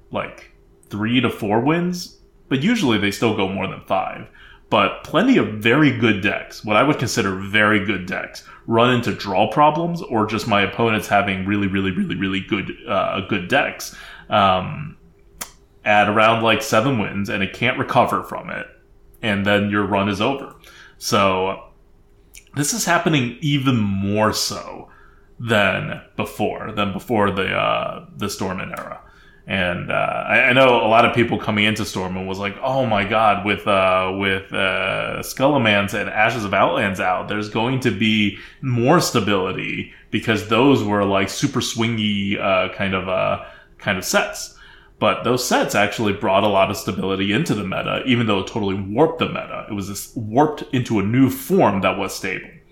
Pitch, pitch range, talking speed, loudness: 105 Hz, 100-120 Hz, 175 wpm, -19 LUFS